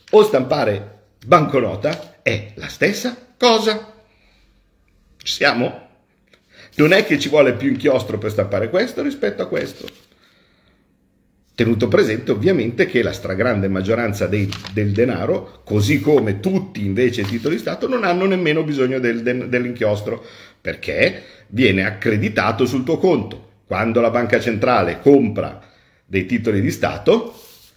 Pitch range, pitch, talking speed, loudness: 105-175 Hz, 125 Hz, 130 wpm, -18 LUFS